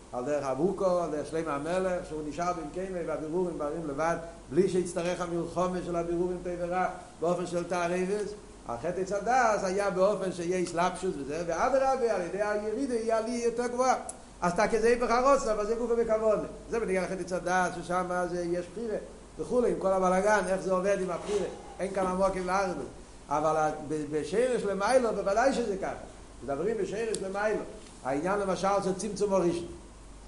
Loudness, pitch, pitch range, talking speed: -30 LUFS, 185 Hz, 175-210 Hz, 165 wpm